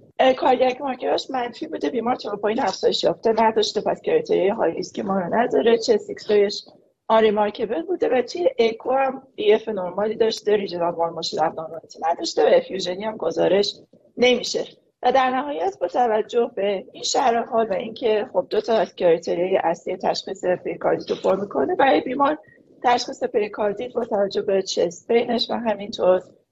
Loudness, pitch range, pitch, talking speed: -22 LUFS, 200-265 Hz, 225 Hz, 170 wpm